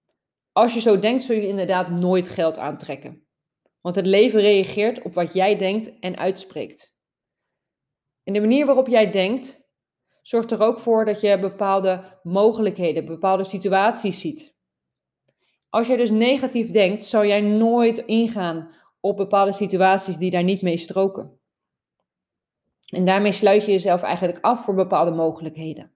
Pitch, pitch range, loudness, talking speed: 195 Hz, 185-220 Hz, -20 LUFS, 150 wpm